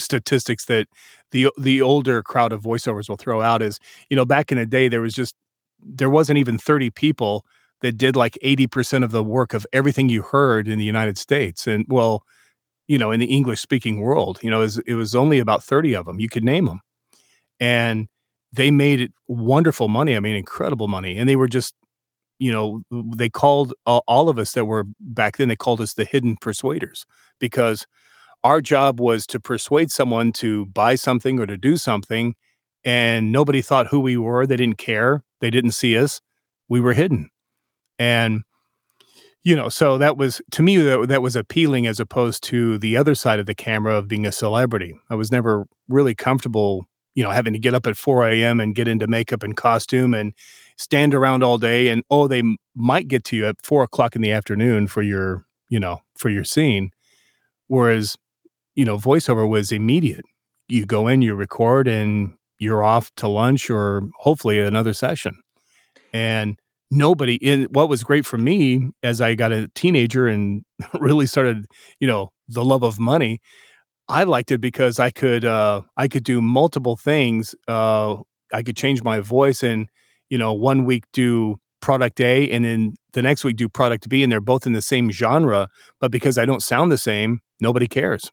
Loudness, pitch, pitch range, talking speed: -19 LUFS, 120 Hz, 110-135 Hz, 195 wpm